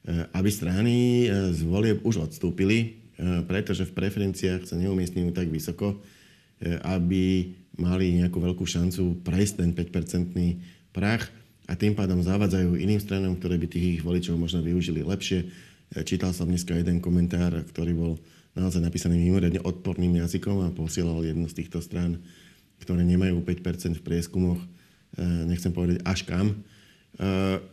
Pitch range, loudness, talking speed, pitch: 85-95 Hz, -27 LUFS, 135 wpm, 90 Hz